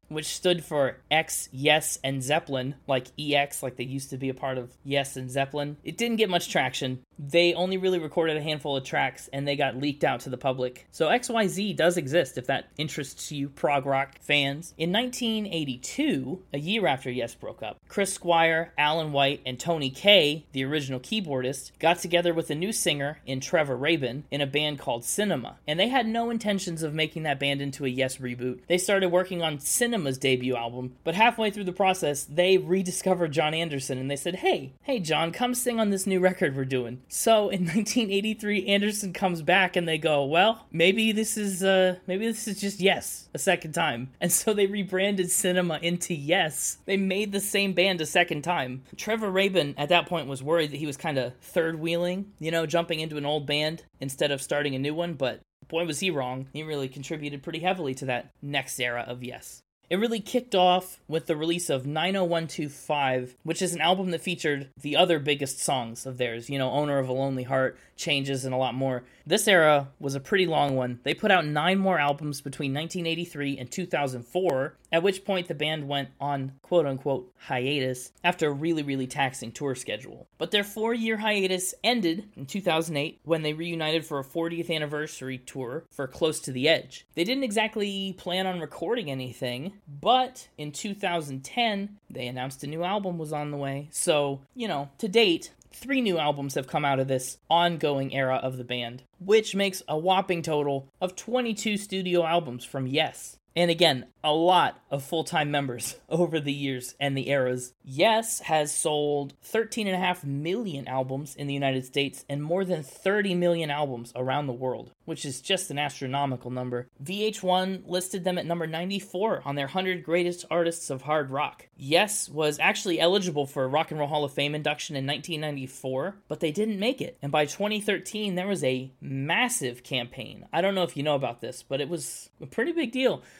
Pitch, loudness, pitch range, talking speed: 155 Hz, -27 LUFS, 135-185 Hz, 195 wpm